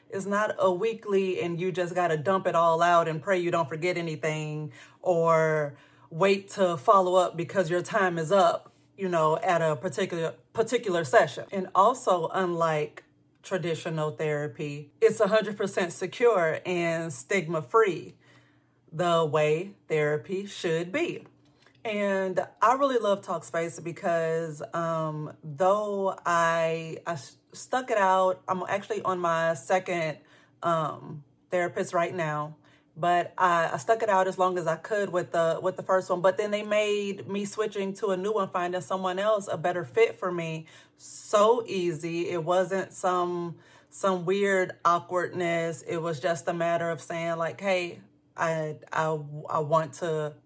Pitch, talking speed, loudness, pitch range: 175 Hz, 155 wpm, -27 LUFS, 160-190 Hz